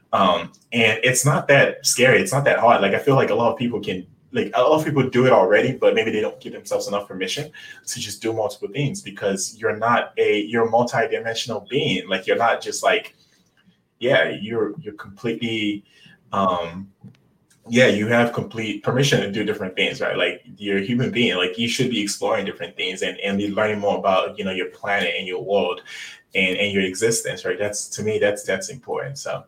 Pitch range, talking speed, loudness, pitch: 100-150 Hz, 215 wpm, -20 LUFS, 115 Hz